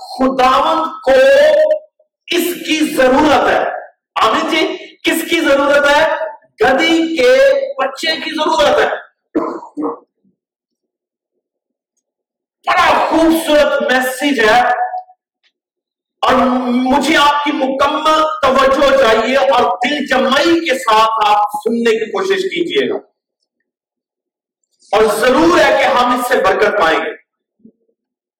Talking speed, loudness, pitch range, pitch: 105 wpm, -12 LUFS, 255-315 Hz, 285 Hz